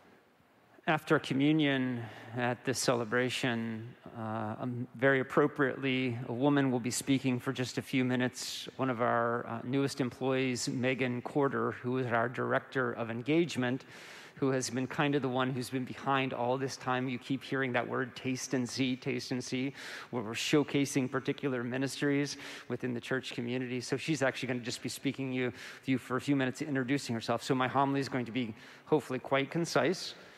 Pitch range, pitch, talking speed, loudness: 125-135 Hz, 130 Hz, 180 wpm, -33 LUFS